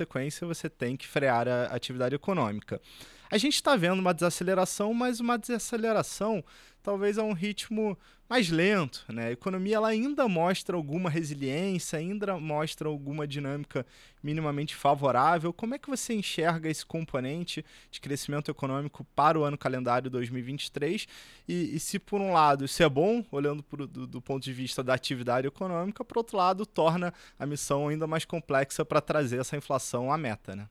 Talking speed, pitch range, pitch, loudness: 170 wpm, 140-195 Hz, 155 Hz, -30 LUFS